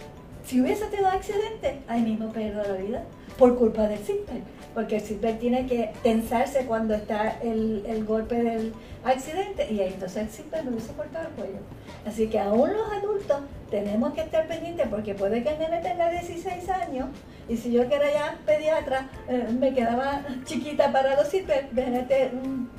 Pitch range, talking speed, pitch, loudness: 225-305 Hz, 185 wpm, 255 Hz, -27 LUFS